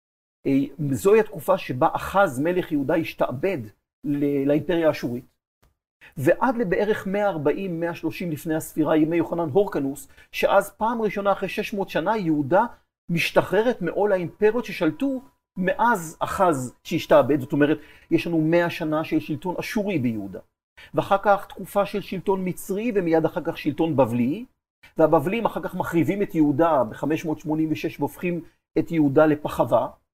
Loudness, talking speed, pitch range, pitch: -23 LUFS, 130 wpm, 155-195 Hz, 170 Hz